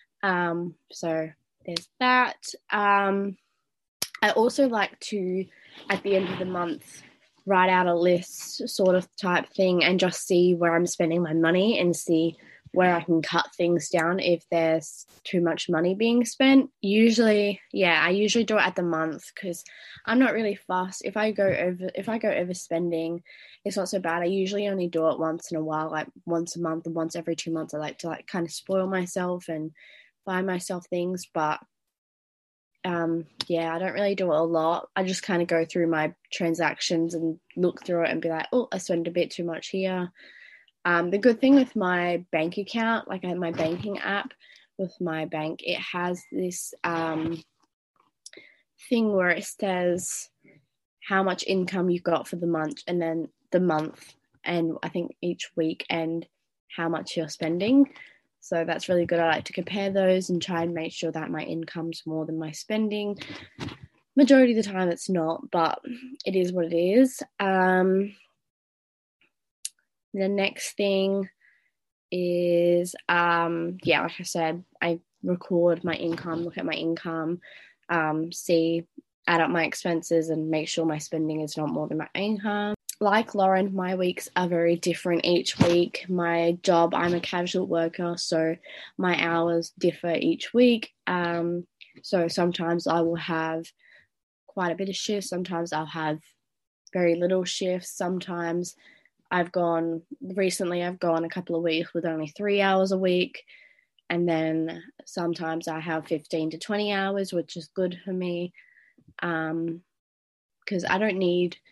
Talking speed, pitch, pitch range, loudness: 175 wpm, 175 Hz, 165-190 Hz, -26 LUFS